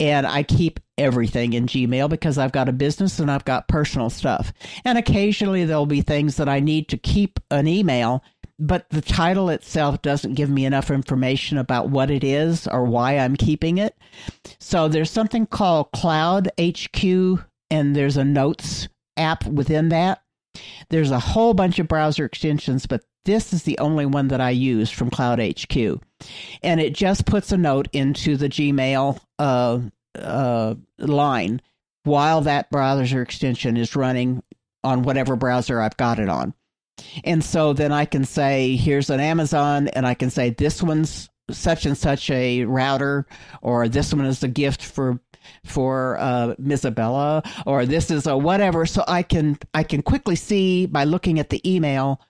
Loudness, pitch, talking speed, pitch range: -21 LUFS, 145 Hz, 170 wpm, 130-160 Hz